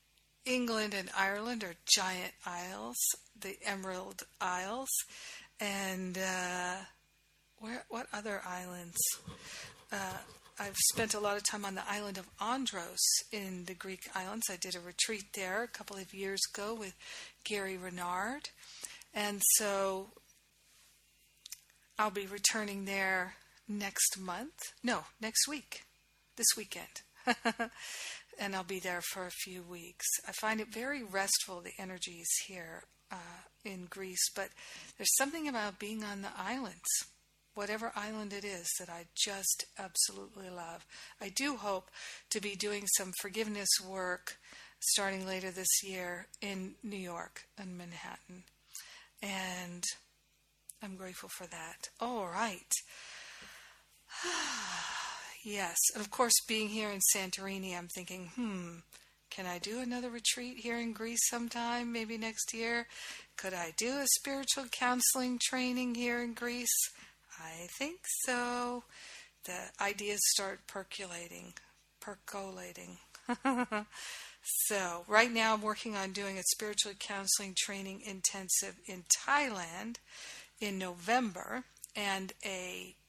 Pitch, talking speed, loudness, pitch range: 200 Hz, 130 wpm, -35 LUFS, 185-225 Hz